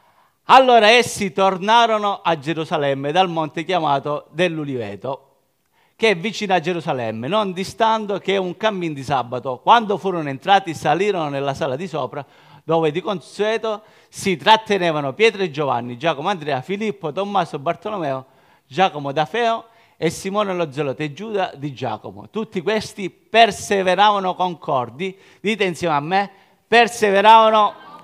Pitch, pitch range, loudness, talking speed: 185 Hz, 150-210 Hz, -19 LUFS, 135 wpm